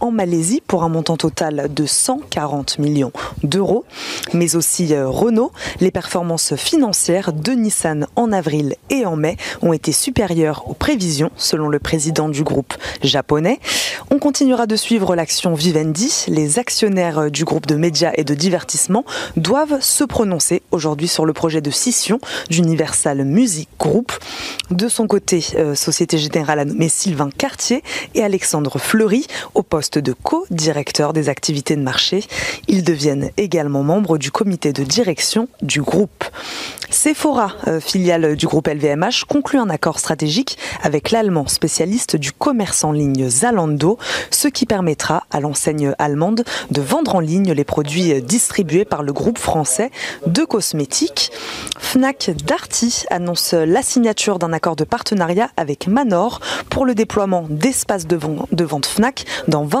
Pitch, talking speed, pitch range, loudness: 170 Hz, 145 wpm, 155-225 Hz, -17 LUFS